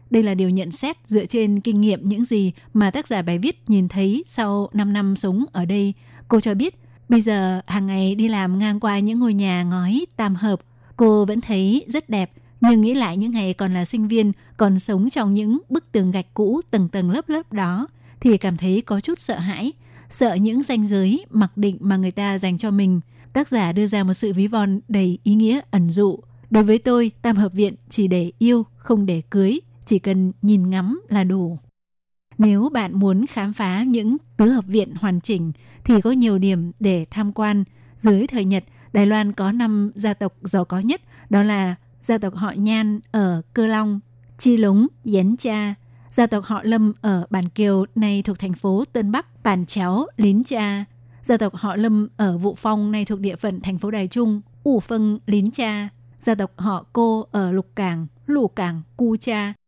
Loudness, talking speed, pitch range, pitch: -20 LUFS, 210 wpm, 190-225 Hz, 205 Hz